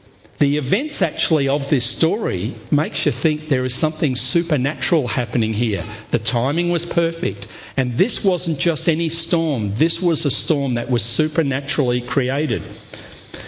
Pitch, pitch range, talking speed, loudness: 145 Hz, 120-165 Hz, 145 wpm, -19 LUFS